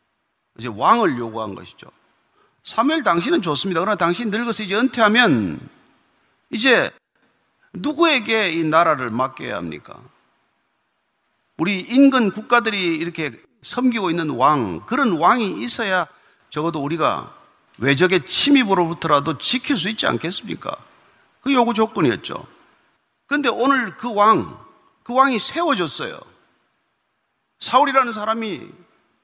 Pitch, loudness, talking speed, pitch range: 220 Hz, -19 LUFS, 270 characters per minute, 170-255 Hz